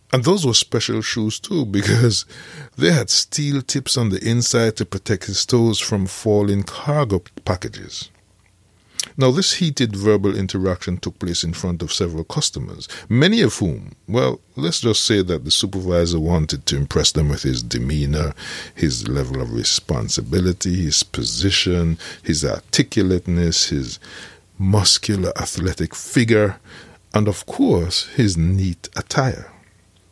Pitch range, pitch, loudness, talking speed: 85-115 Hz, 95 Hz, -19 LUFS, 135 wpm